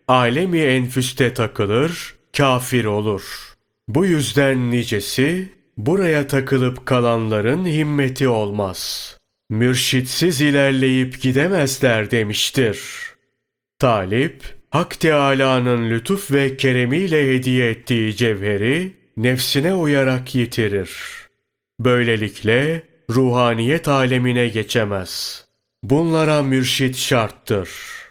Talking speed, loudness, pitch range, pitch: 75 wpm, -18 LUFS, 120-140 Hz, 130 Hz